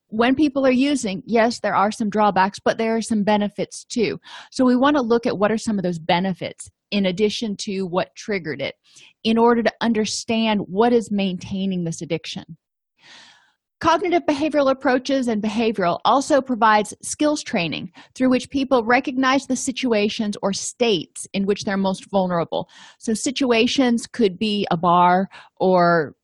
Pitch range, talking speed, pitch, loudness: 195-255 Hz, 160 wpm, 220 Hz, -20 LUFS